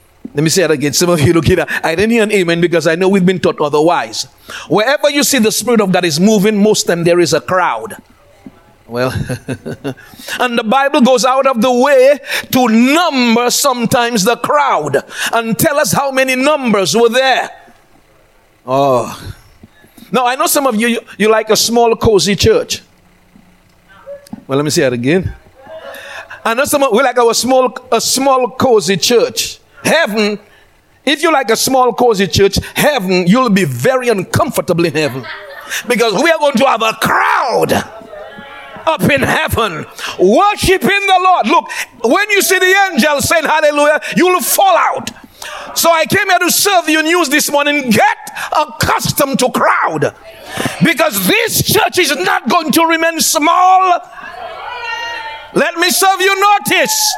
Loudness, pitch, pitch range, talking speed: -12 LUFS, 250 Hz, 210-320 Hz, 170 wpm